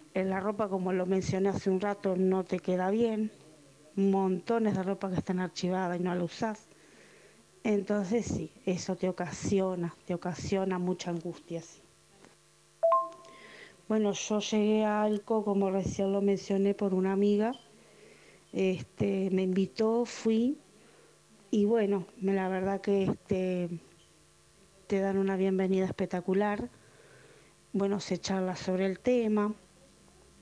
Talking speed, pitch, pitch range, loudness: 130 wpm, 195 Hz, 185-210 Hz, -31 LUFS